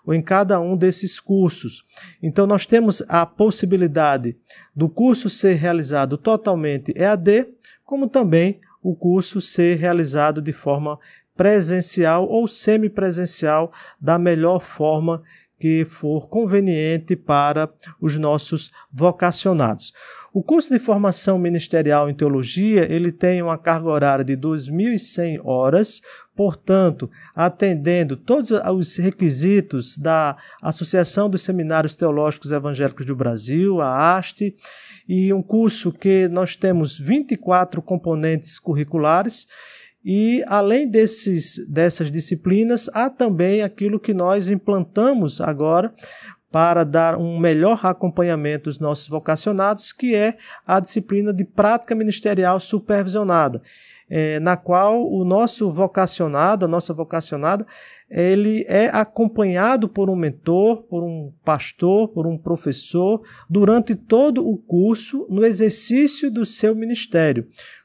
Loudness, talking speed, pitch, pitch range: -19 LUFS, 120 wpm, 180 Hz, 160-205 Hz